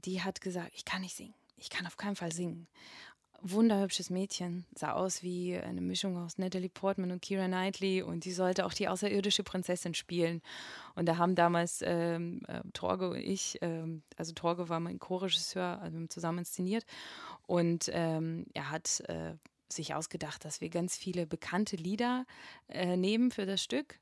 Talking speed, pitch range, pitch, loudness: 175 wpm, 170-190 Hz, 180 Hz, -35 LUFS